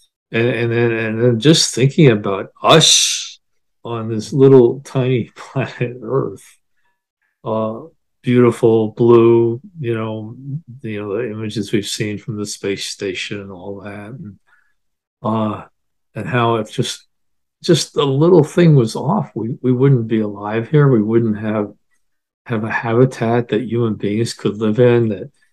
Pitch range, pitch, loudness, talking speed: 110-125 Hz, 115 Hz, -16 LUFS, 150 wpm